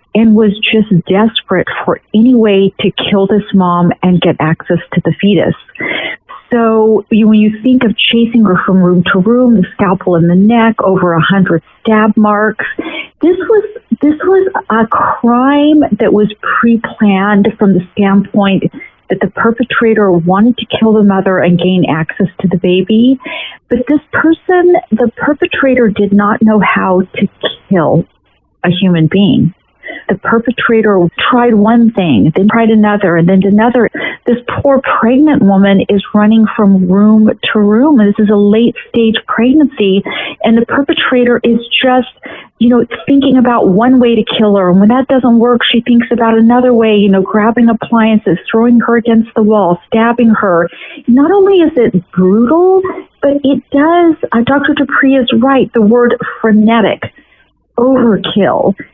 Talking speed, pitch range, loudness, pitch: 160 wpm, 200-245 Hz, -9 LUFS, 225 Hz